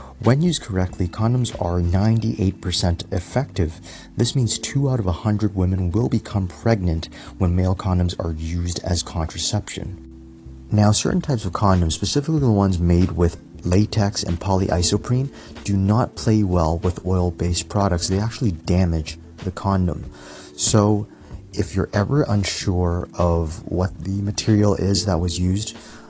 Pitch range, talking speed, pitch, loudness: 85-105 Hz, 145 wpm, 95 Hz, -20 LUFS